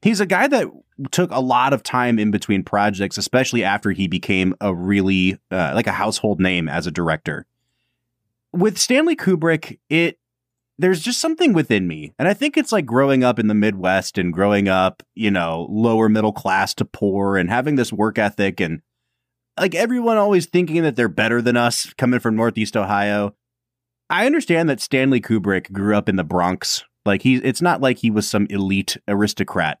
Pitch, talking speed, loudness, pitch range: 110 Hz, 190 wpm, -19 LUFS, 100-135 Hz